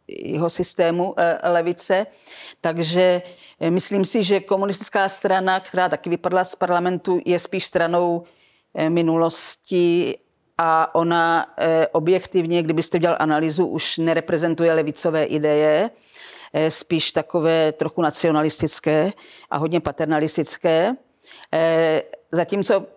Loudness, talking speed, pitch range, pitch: -20 LUFS, 95 wpm, 165-185 Hz, 170 Hz